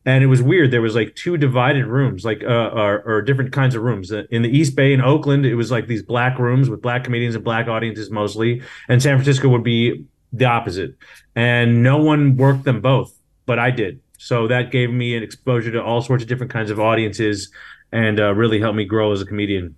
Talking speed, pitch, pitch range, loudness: 230 wpm, 120 Hz, 110-130 Hz, -18 LUFS